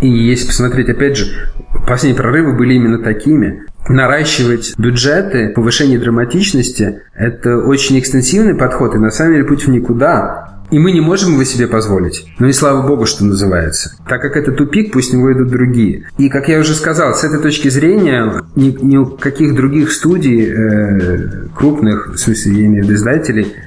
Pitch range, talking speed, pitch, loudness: 110-145 Hz, 180 wpm, 125 Hz, -11 LUFS